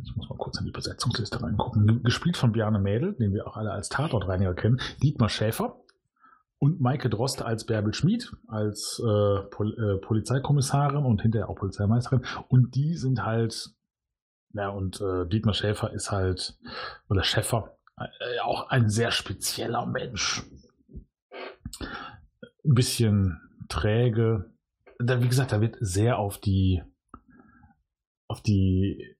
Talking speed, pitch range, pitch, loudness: 140 wpm, 100-125 Hz, 110 Hz, -27 LUFS